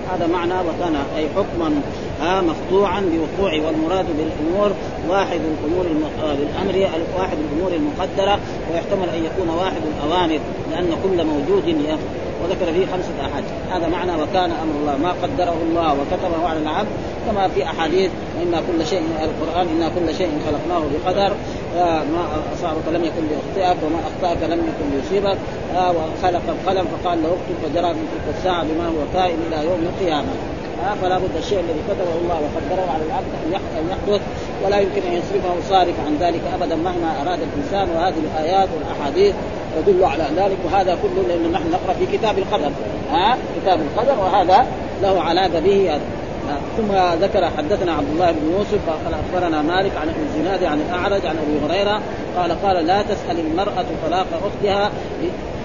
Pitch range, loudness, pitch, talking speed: 160-190 Hz, -20 LUFS, 175 Hz, 160 wpm